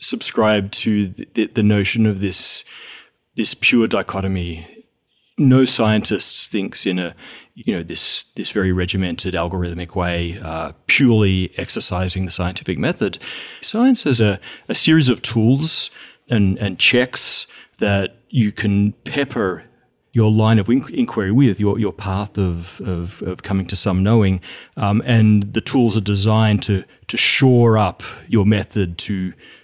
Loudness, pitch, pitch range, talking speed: -18 LUFS, 105 Hz, 95-115 Hz, 140 wpm